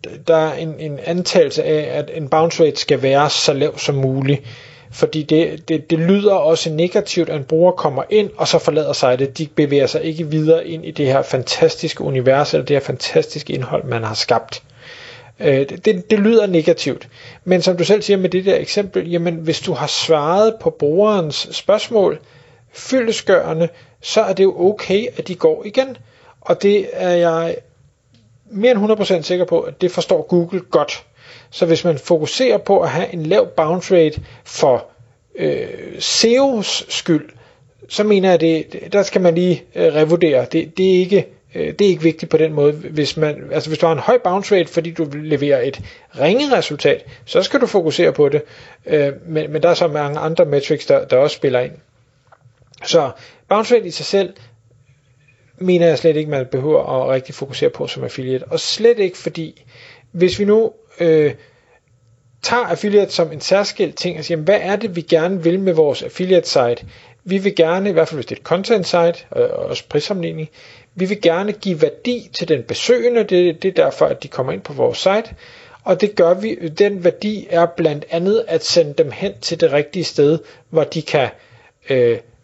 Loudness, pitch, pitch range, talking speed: -16 LUFS, 170 Hz, 155-200 Hz, 200 wpm